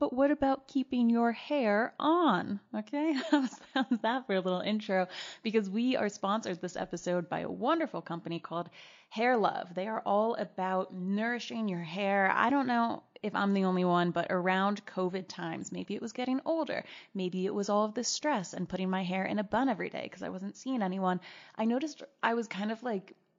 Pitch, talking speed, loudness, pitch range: 210 Hz, 205 wpm, -32 LUFS, 185-250 Hz